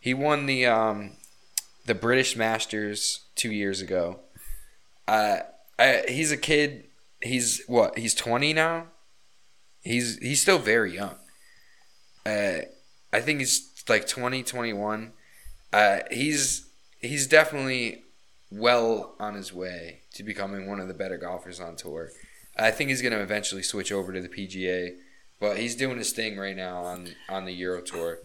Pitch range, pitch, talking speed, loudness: 100-135 Hz, 115 Hz, 155 wpm, -26 LUFS